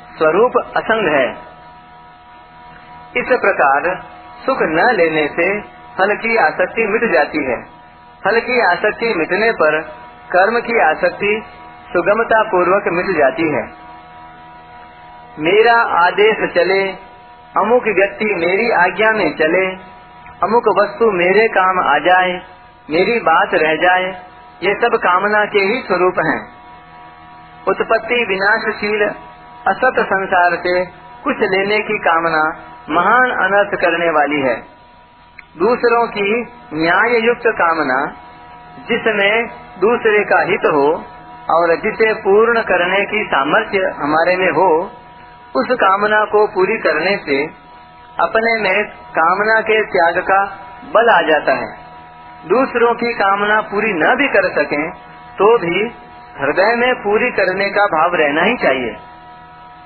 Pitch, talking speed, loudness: 185 Hz, 120 wpm, -14 LUFS